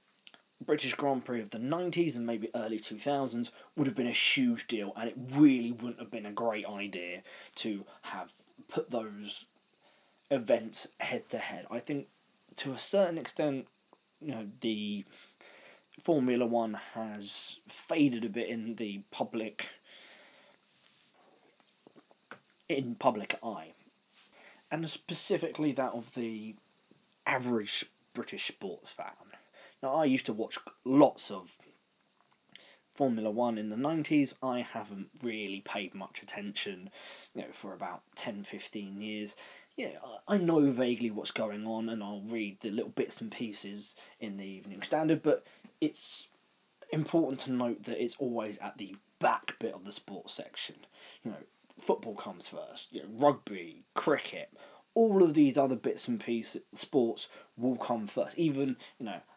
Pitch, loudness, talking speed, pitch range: 120 Hz, -34 LUFS, 150 wpm, 110-145 Hz